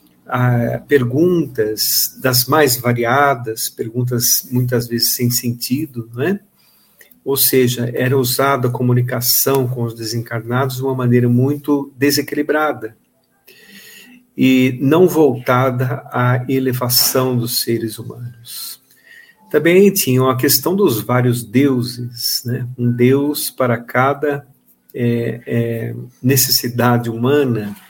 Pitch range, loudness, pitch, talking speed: 120-140 Hz, -16 LUFS, 125 Hz, 105 wpm